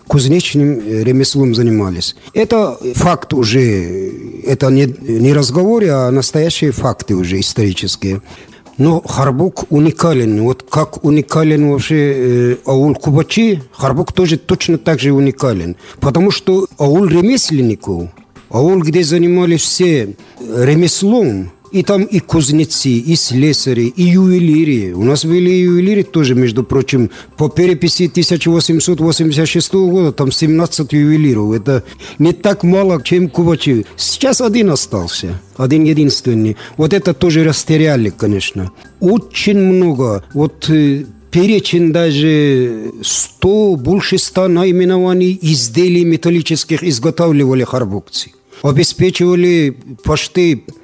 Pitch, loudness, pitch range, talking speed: 155 Hz, -12 LUFS, 130-175 Hz, 110 wpm